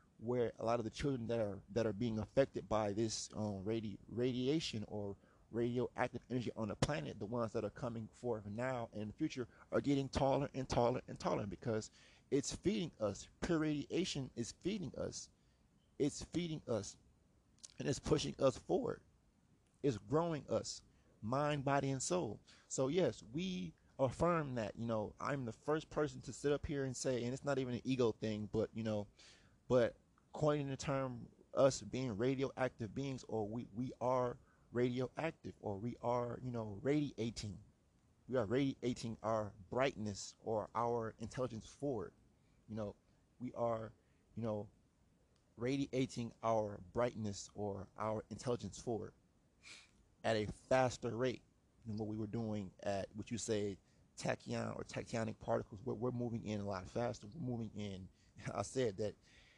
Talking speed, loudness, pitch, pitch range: 160 wpm, -41 LUFS, 115 Hz, 105-130 Hz